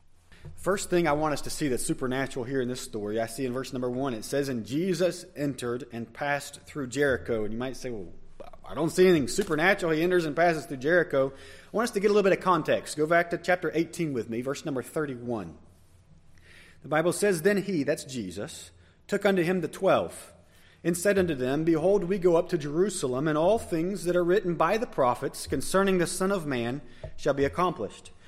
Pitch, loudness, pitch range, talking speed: 150 Hz, -27 LUFS, 120-175 Hz, 220 wpm